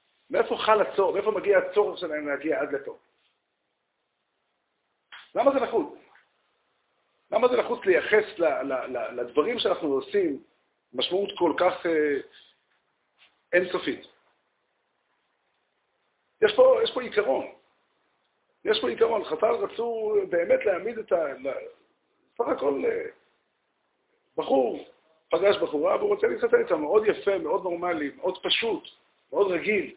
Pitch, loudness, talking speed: 380 Hz, -25 LUFS, 110 wpm